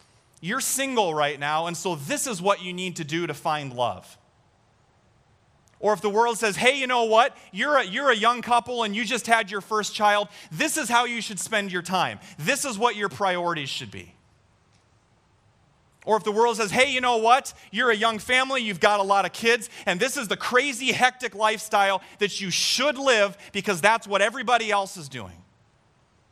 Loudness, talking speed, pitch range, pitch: -23 LUFS, 205 wpm, 165-235 Hz, 205 Hz